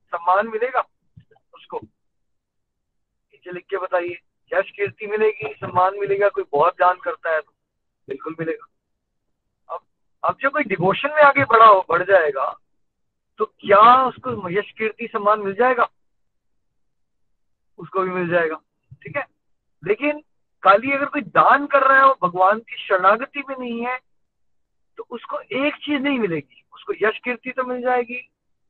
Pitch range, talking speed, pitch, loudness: 185-270 Hz, 150 wpm, 220 Hz, -19 LUFS